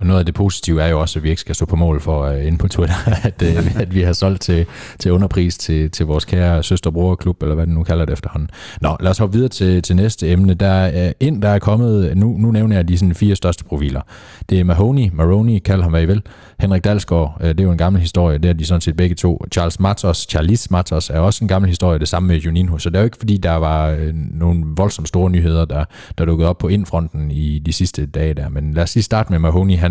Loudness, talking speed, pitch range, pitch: -16 LUFS, 270 wpm, 80-95 Hz, 90 Hz